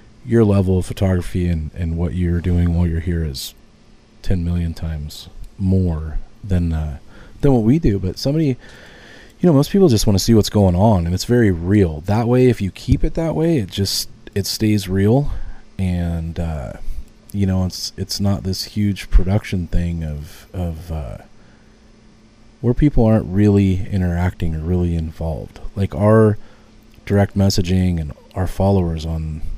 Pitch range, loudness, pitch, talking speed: 85-110 Hz, -18 LUFS, 95 Hz, 170 wpm